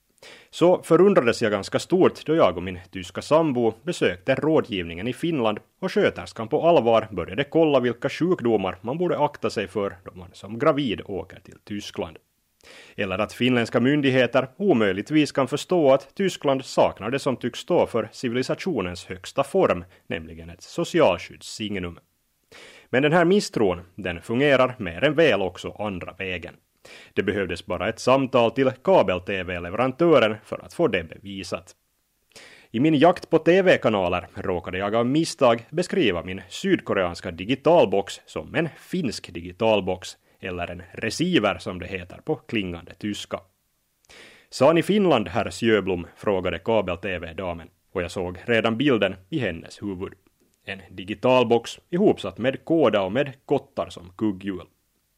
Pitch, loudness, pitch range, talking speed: 110 Hz, -23 LUFS, 90-135 Hz, 140 wpm